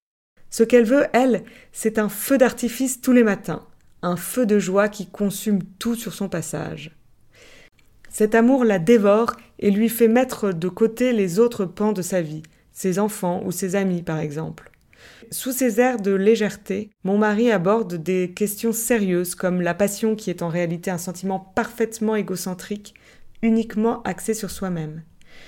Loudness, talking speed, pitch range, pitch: -21 LUFS, 165 wpm, 185-230 Hz, 205 Hz